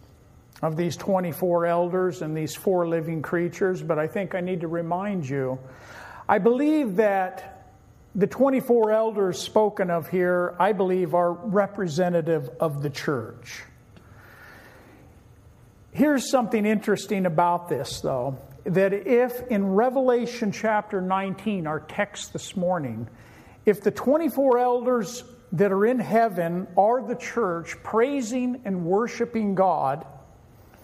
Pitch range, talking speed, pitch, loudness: 160-215 Hz, 125 wpm, 185 Hz, -24 LUFS